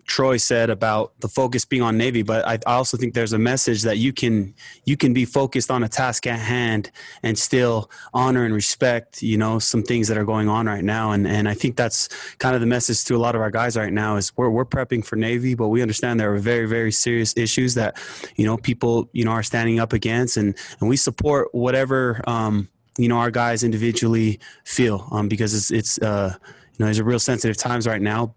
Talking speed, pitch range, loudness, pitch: 235 wpm, 110-125 Hz, -21 LUFS, 115 Hz